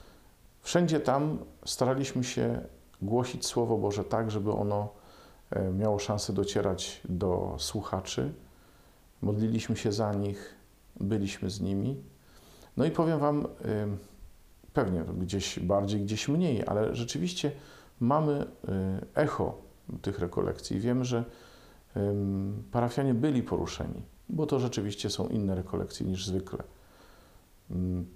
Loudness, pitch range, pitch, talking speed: -31 LUFS, 95-120 Hz, 105 Hz, 105 wpm